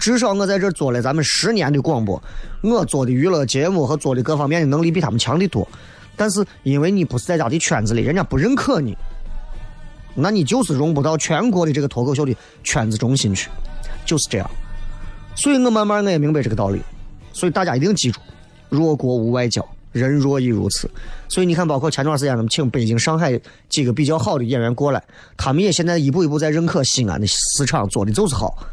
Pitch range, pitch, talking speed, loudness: 120-165 Hz, 145 Hz, 335 characters per minute, -18 LUFS